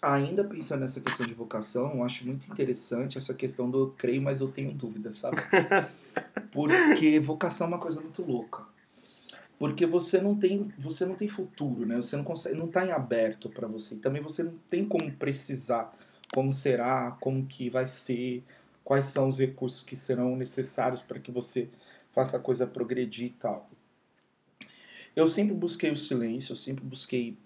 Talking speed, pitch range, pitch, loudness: 175 wpm, 125-155 Hz, 130 Hz, -30 LUFS